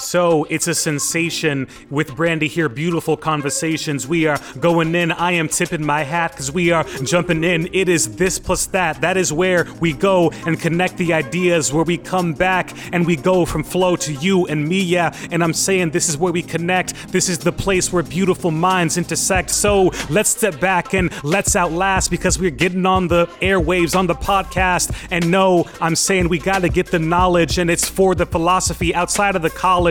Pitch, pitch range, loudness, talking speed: 175 Hz, 165-185 Hz, -17 LUFS, 205 wpm